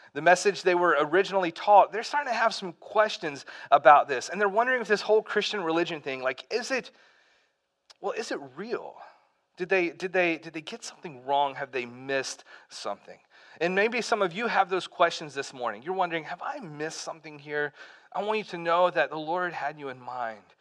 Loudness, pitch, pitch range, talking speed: -27 LUFS, 175 Hz, 150-205 Hz, 210 wpm